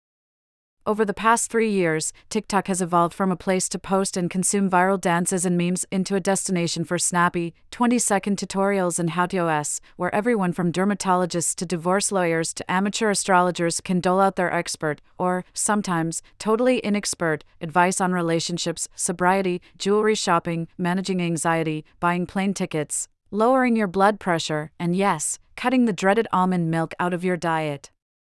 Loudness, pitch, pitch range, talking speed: -22 LUFS, 180 Hz, 170-195 Hz, 155 wpm